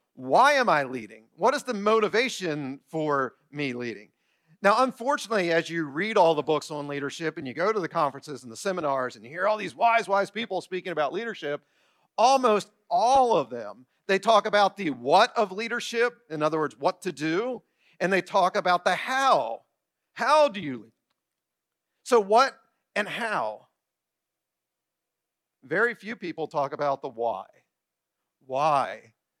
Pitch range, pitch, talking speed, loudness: 150-225 Hz, 185 Hz, 165 wpm, -25 LUFS